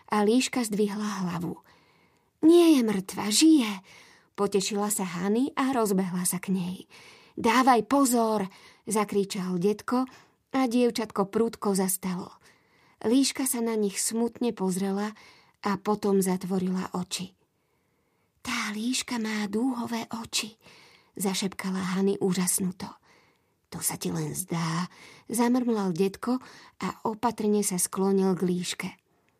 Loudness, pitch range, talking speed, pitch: -27 LUFS, 190-230 Hz, 110 wpm, 205 Hz